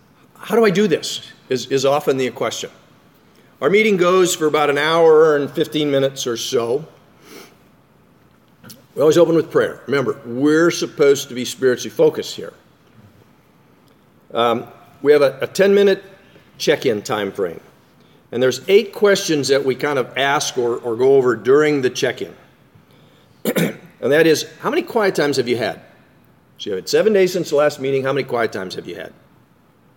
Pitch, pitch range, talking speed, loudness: 155 Hz, 135-200 Hz, 170 wpm, -17 LUFS